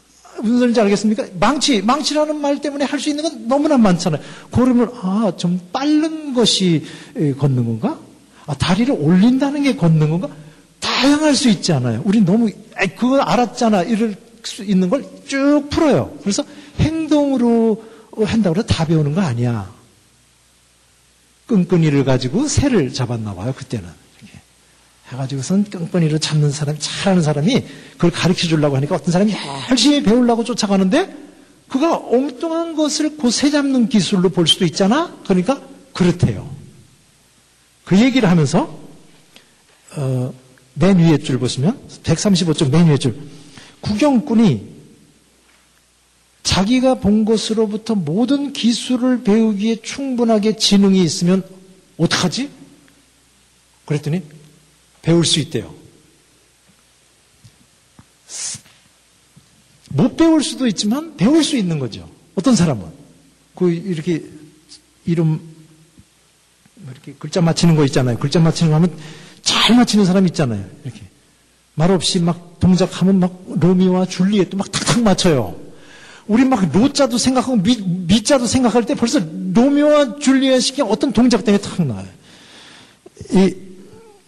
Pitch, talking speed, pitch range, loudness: 190 Hz, 275 characters per minute, 155-240 Hz, -16 LUFS